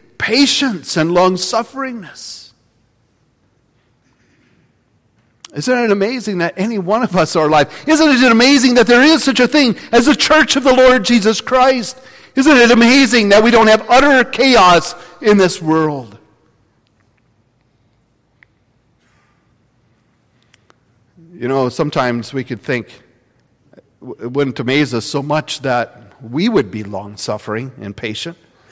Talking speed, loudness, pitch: 125 wpm, -12 LUFS, 145 Hz